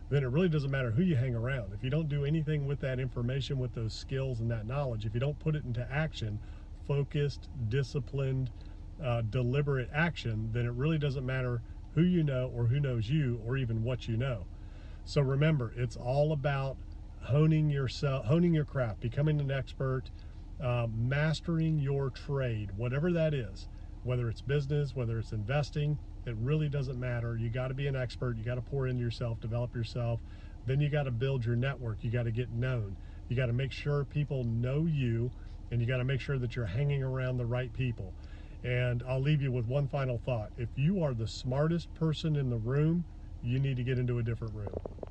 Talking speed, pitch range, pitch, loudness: 205 wpm, 115-140 Hz, 125 Hz, -33 LUFS